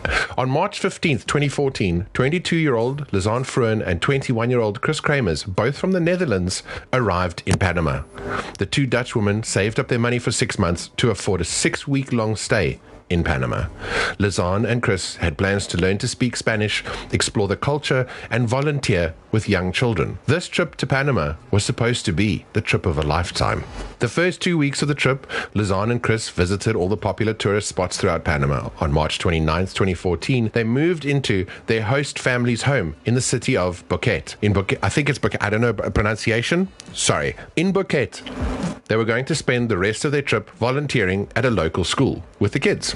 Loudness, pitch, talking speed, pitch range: -21 LUFS, 115 Hz, 185 wpm, 95-135 Hz